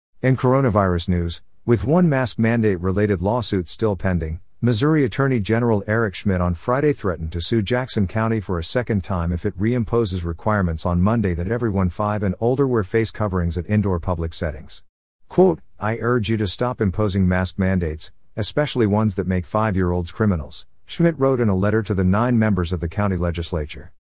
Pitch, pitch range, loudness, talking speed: 105 Hz, 90-115 Hz, -21 LUFS, 180 wpm